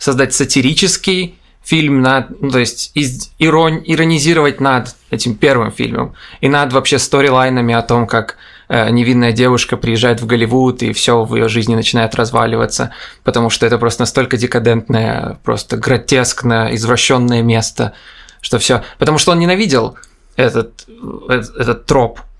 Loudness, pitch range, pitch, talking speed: -13 LUFS, 115-140 Hz, 125 Hz, 140 wpm